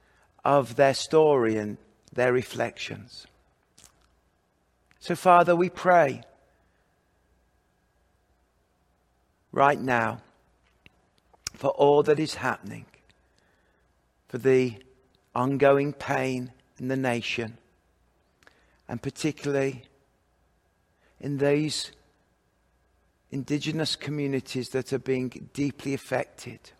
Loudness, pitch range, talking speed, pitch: -26 LUFS, 95-140 Hz, 80 wpm, 130 Hz